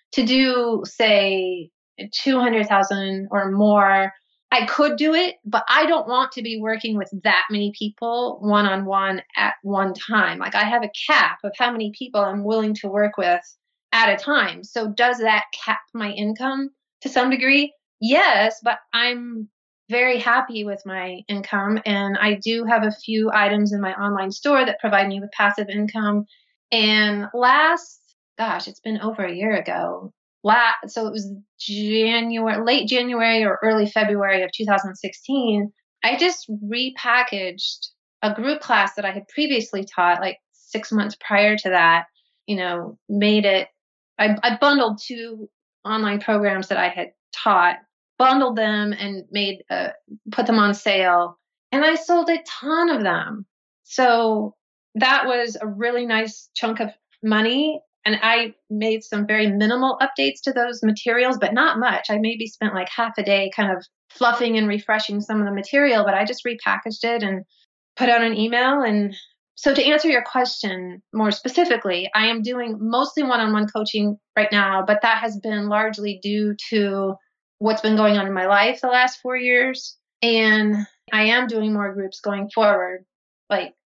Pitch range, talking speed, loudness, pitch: 205-245 Hz, 170 wpm, -20 LUFS, 215 Hz